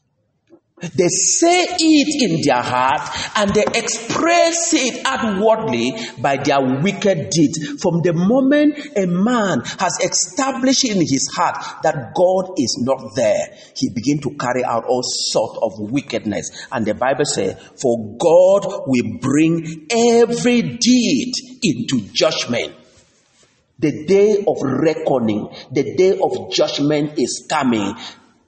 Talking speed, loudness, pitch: 130 wpm, -17 LUFS, 190 Hz